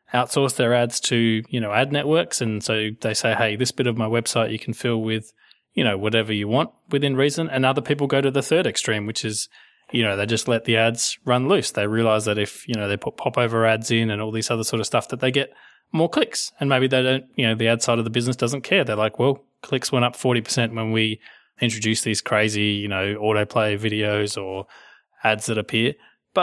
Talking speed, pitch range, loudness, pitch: 240 wpm, 110-130 Hz, -22 LUFS, 115 Hz